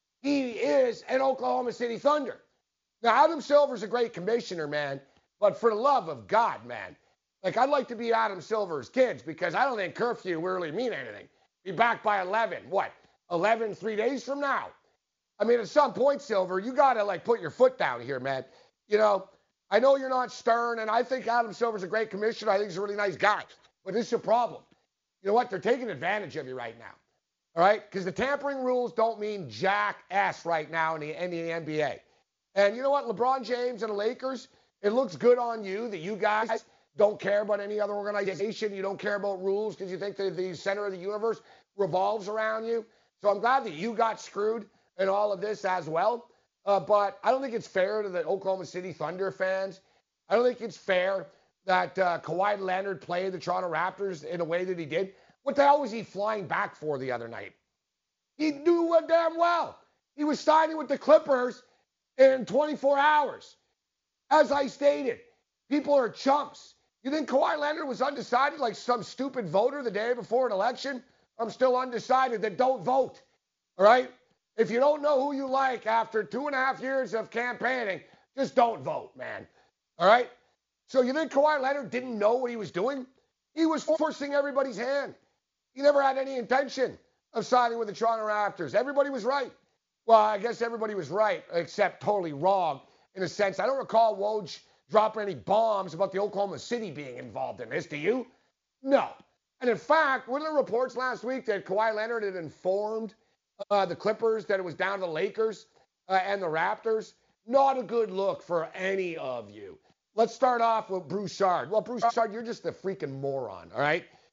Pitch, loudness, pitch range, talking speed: 225 Hz, -28 LUFS, 195-260 Hz, 200 wpm